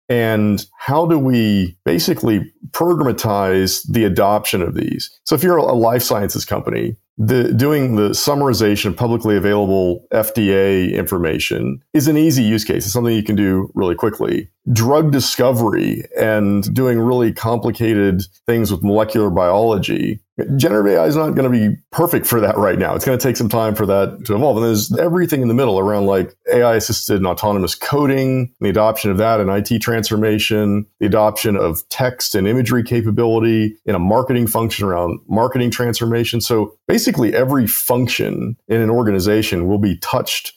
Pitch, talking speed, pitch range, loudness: 110 Hz, 170 wpm, 100-120 Hz, -16 LUFS